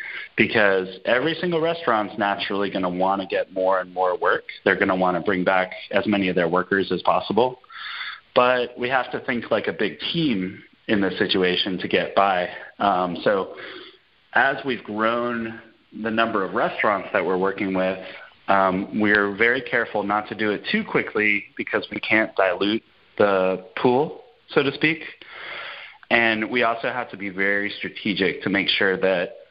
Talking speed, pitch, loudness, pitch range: 175 wpm, 100 Hz, -22 LUFS, 95-115 Hz